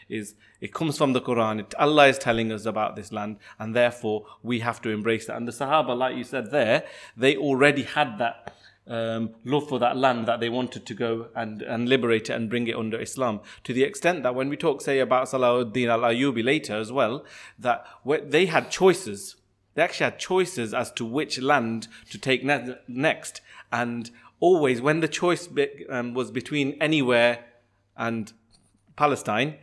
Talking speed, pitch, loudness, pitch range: 190 wpm, 120 Hz, -25 LUFS, 115-140 Hz